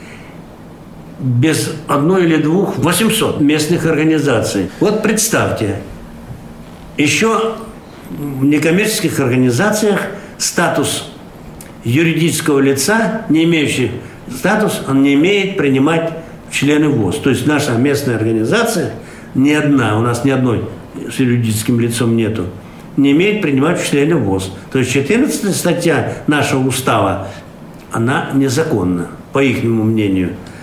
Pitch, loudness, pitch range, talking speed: 140 Hz, -14 LUFS, 115-165 Hz, 115 wpm